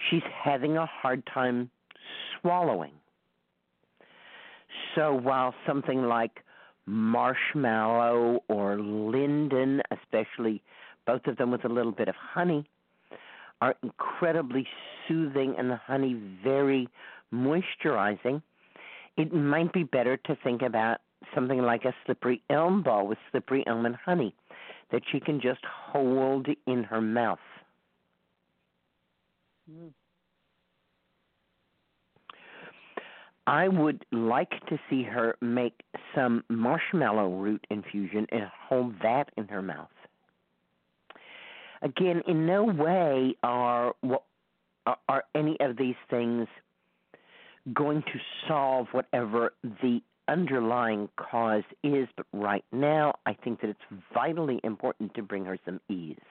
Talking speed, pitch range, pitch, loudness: 115 wpm, 105-140 Hz, 125 Hz, -29 LUFS